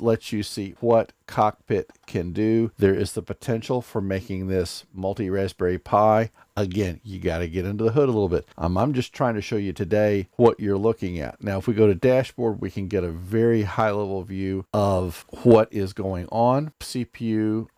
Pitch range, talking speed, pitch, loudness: 95-115 Hz, 205 wpm, 105 Hz, -24 LUFS